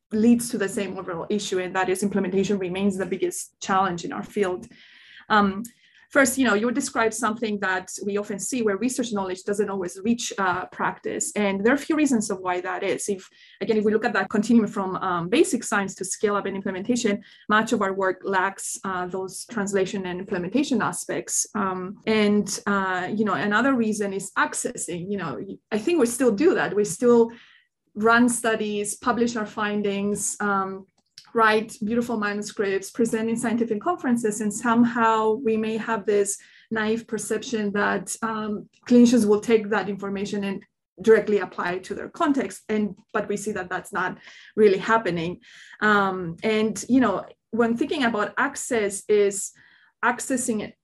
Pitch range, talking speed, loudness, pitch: 195-230 Hz, 175 wpm, -24 LUFS, 210 Hz